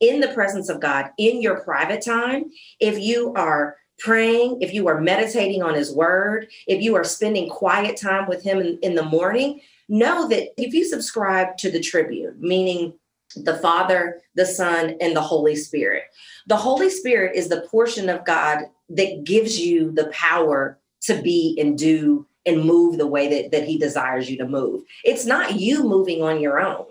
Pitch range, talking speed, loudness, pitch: 160-220 Hz, 185 wpm, -20 LUFS, 185 Hz